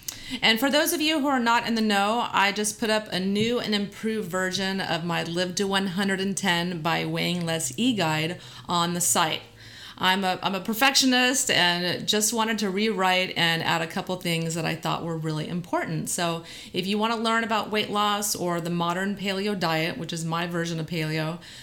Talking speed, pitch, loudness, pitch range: 205 wpm, 190 Hz, -24 LUFS, 170-215 Hz